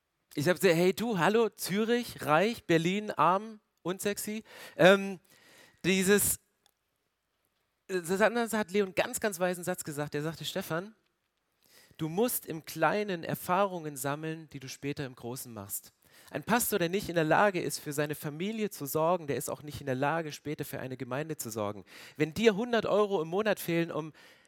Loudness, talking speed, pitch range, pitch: -30 LUFS, 175 wpm, 150-205 Hz, 175 Hz